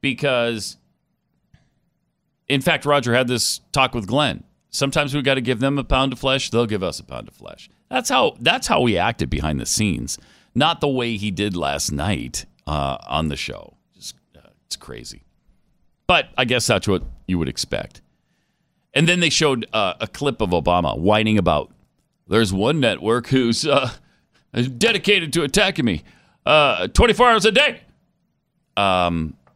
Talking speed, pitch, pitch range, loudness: 170 wpm, 120 Hz, 90-140 Hz, -19 LUFS